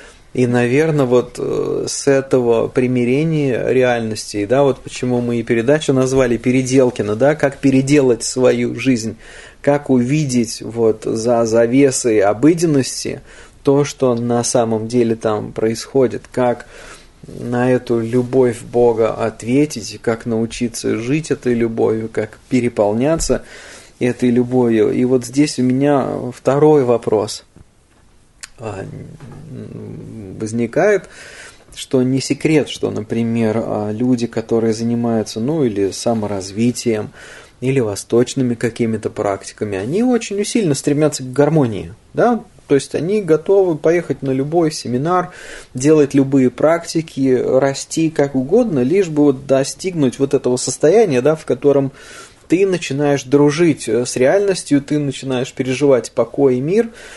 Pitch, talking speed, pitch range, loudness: 130 Hz, 120 wpm, 120-145 Hz, -16 LUFS